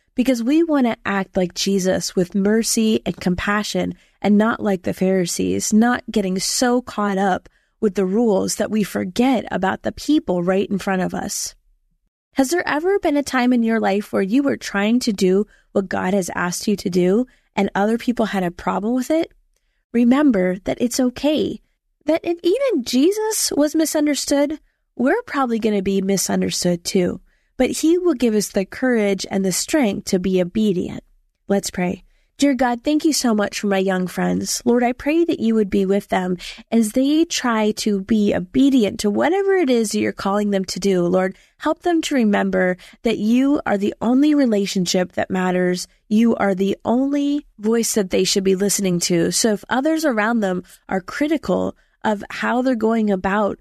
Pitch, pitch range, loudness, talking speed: 215 Hz, 195-260 Hz, -19 LUFS, 190 wpm